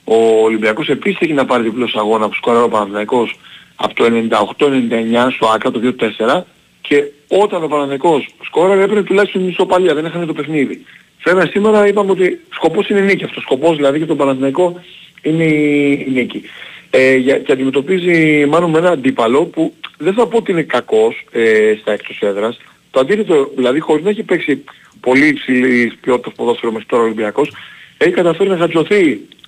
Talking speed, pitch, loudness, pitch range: 175 wpm, 150 Hz, -14 LUFS, 125-185 Hz